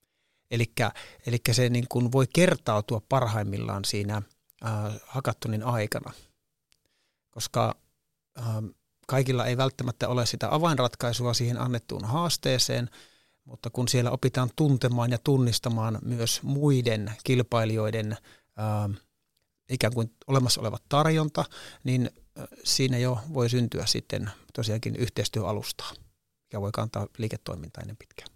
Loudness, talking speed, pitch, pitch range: -28 LUFS, 110 wpm, 120 Hz, 110-130 Hz